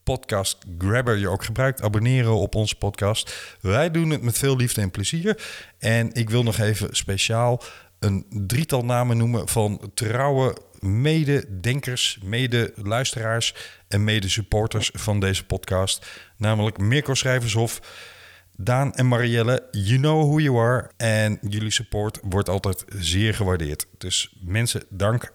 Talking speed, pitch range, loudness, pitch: 135 wpm, 100-125 Hz, -23 LUFS, 110 Hz